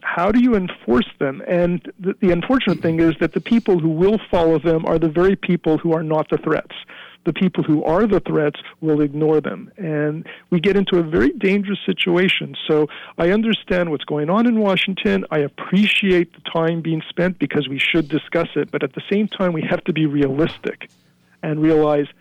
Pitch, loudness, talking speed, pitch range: 170 Hz, -19 LUFS, 205 wpm, 155-190 Hz